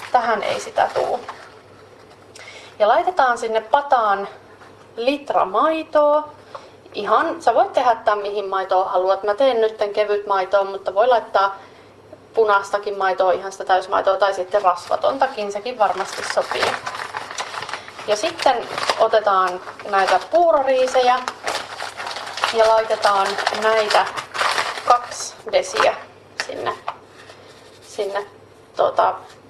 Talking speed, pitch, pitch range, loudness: 100 wpm, 210 Hz, 195-255 Hz, -19 LUFS